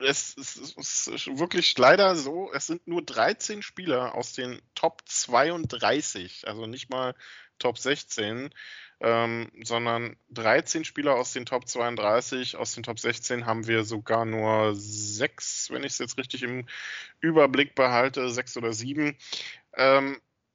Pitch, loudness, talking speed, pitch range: 125 Hz, -27 LUFS, 145 wpm, 115-135 Hz